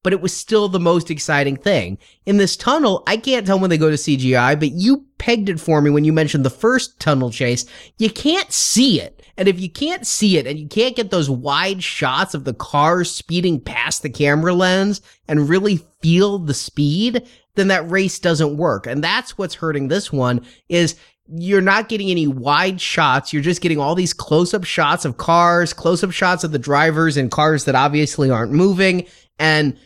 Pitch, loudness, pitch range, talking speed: 170 Hz, -17 LUFS, 145-195 Hz, 205 wpm